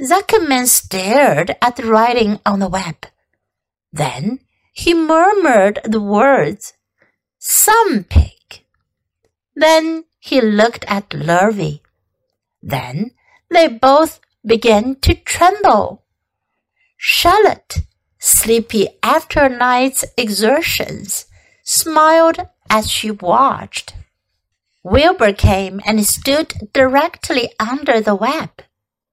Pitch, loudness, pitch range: 235 Hz, -14 LUFS, 195-315 Hz